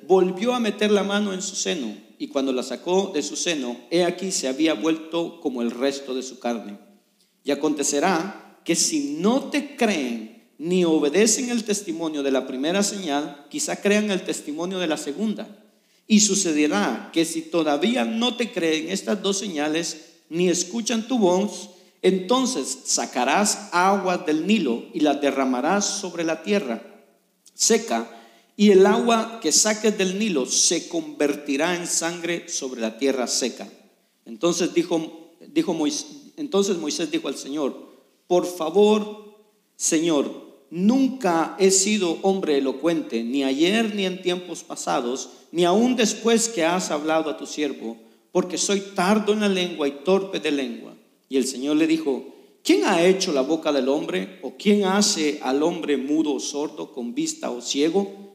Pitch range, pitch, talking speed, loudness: 150-205 Hz, 175 Hz, 160 wpm, -22 LUFS